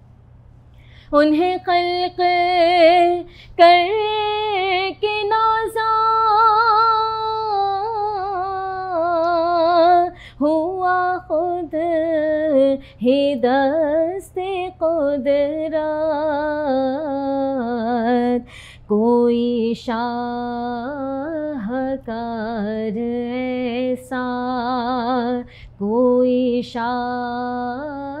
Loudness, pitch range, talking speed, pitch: -19 LUFS, 245-360 Hz, 35 wpm, 295 Hz